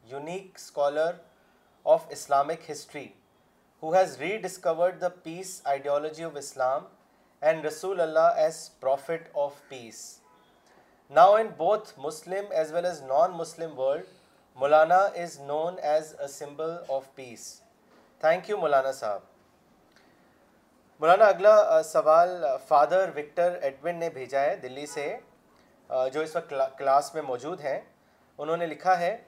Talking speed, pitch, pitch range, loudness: 135 wpm, 160 Hz, 145-180 Hz, -26 LUFS